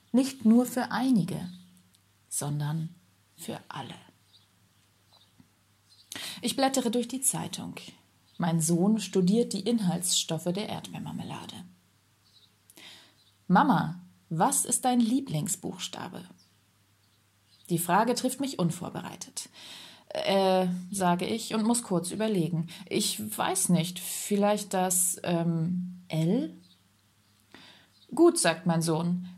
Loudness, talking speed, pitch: -28 LUFS, 95 wpm, 175 Hz